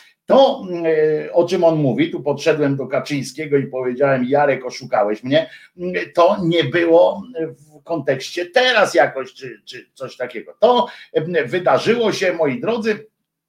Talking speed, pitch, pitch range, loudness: 135 wpm, 160 Hz, 140-185 Hz, -18 LUFS